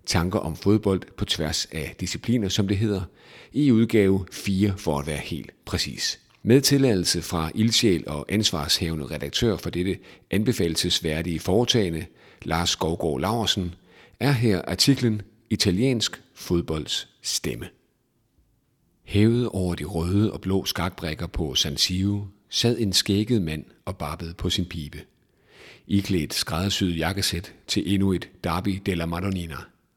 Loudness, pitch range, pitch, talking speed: -24 LUFS, 85-105 Hz, 95 Hz, 130 wpm